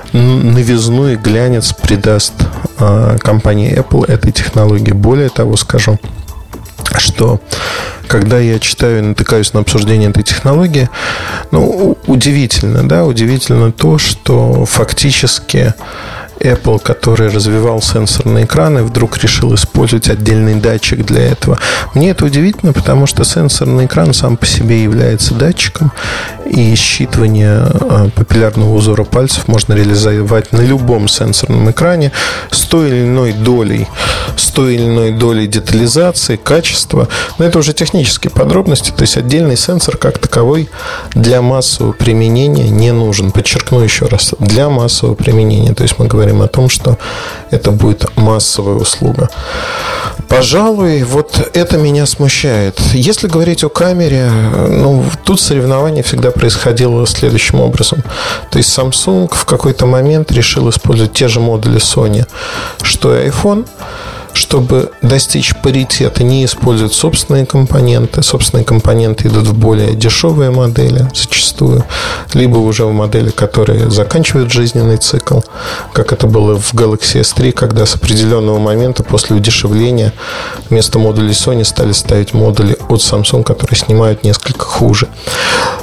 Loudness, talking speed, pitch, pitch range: -10 LUFS, 130 wpm, 115 Hz, 110-130 Hz